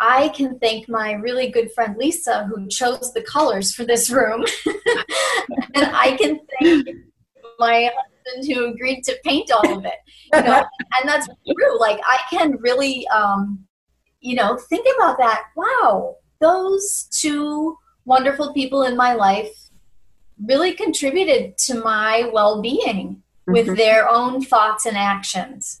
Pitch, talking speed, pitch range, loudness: 250 Hz, 145 wpm, 220-295 Hz, -18 LUFS